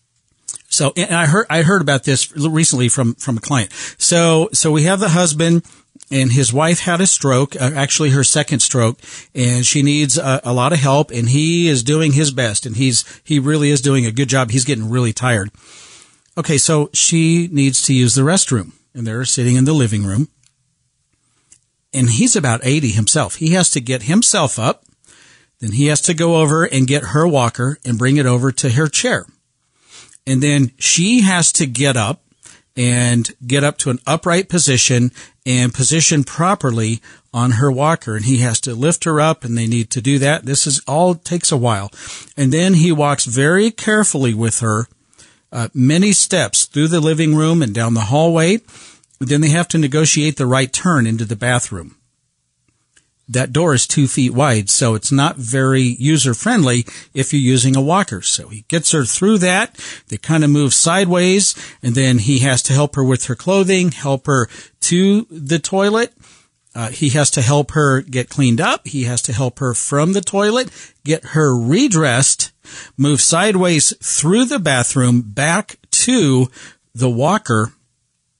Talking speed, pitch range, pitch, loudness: 185 wpm, 125-160 Hz, 140 Hz, -14 LUFS